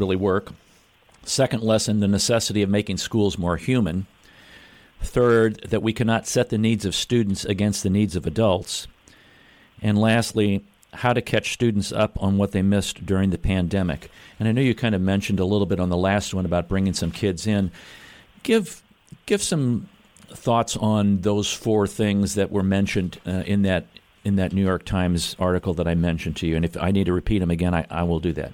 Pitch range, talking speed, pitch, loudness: 90-110 Hz, 200 wpm, 100 Hz, -22 LUFS